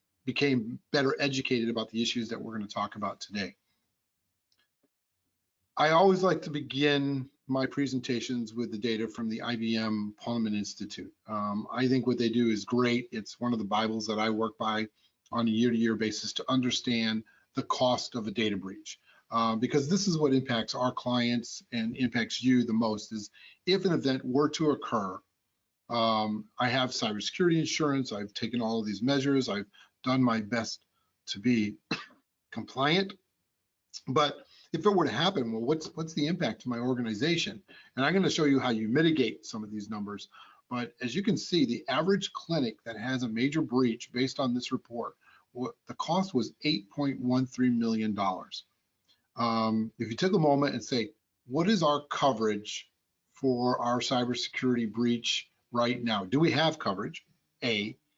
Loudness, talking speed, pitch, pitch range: -30 LUFS, 175 wpm, 120 Hz, 110-140 Hz